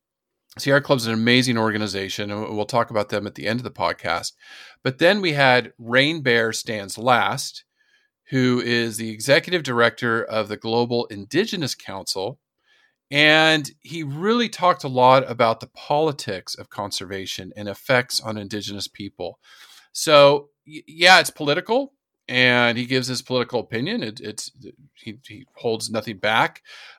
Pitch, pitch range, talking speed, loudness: 125 Hz, 110-145 Hz, 155 wpm, -20 LUFS